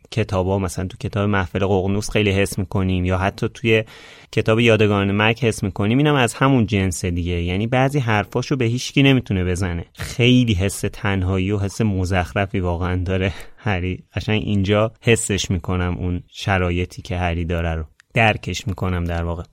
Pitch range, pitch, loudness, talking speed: 90-110 Hz, 100 Hz, -20 LUFS, 165 wpm